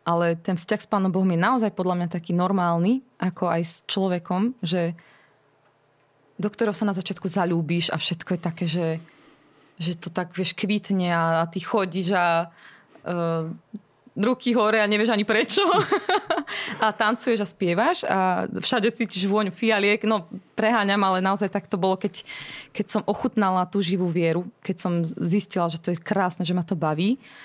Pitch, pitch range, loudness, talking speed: 190 Hz, 175-215 Hz, -24 LUFS, 175 wpm